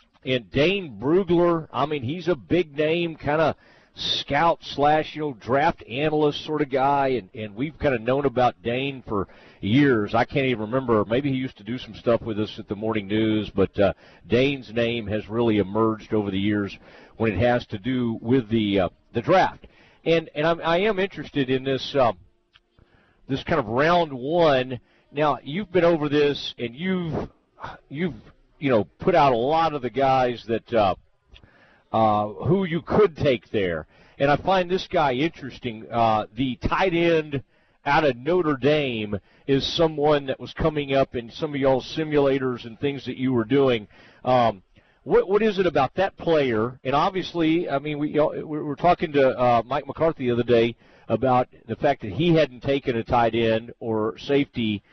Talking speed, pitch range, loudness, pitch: 190 wpm, 115-155 Hz, -23 LUFS, 135 Hz